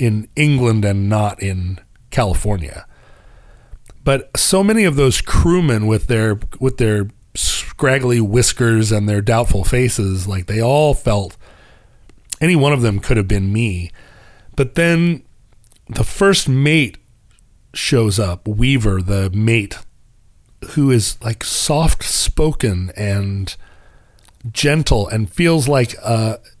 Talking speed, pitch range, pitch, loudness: 125 wpm, 100-130 Hz, 115 Hz, -16 LUFS